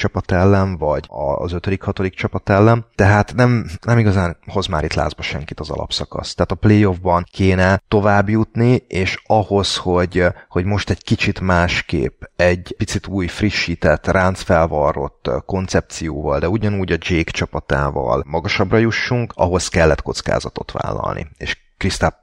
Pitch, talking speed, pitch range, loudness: 95 Hz, 140 wpm, 85-105 Hz, -18 LUFS